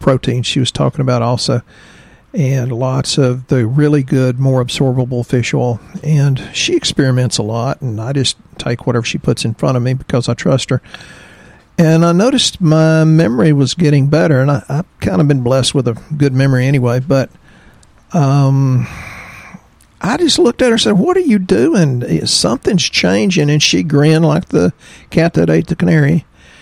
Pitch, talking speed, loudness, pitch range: 135 Hz, 185 wpm, -13 LUFS, 125-160 Hz